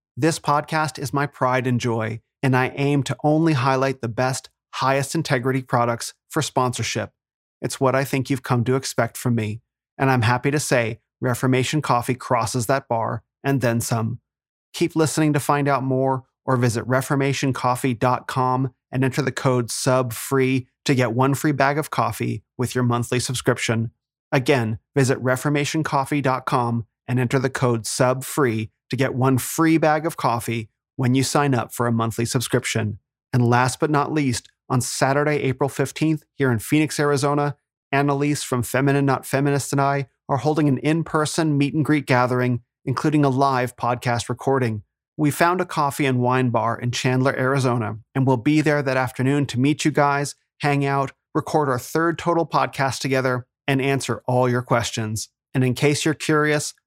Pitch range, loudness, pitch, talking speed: 125-145 Hz, -21 LUFS, 130 Hz, 170 wpm